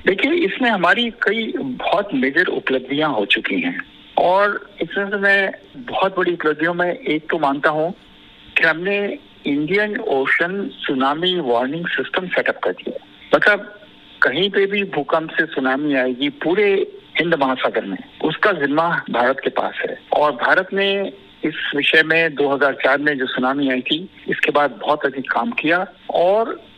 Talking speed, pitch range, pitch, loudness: 155 wpm, 145-205 Hz, 175 Hz, -18 LUFS